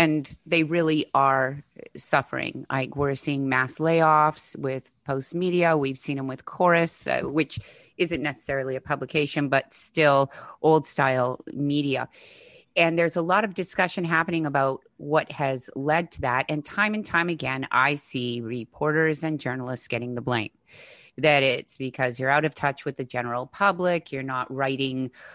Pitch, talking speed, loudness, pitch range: 145 Hz, 165 wpm, -25 LUFS, 130-160 Hz